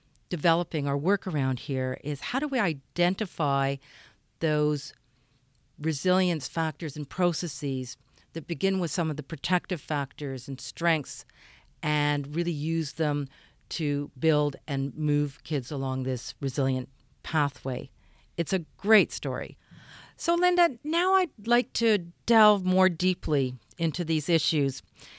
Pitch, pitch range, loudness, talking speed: 155 Hz, 140-175 Hz, -28 LUFS, 130 wpm